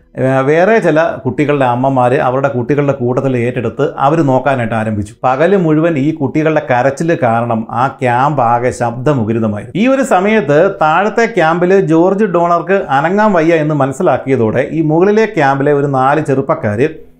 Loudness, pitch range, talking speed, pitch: -12 LUFS, 125-165 Hz, 135 wpm, 145 Hz